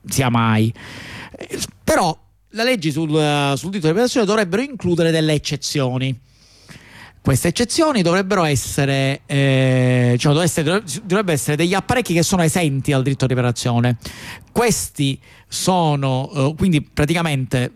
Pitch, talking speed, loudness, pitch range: 145 Hz, 135 wpm, -18 LUFS, 130-175 Hz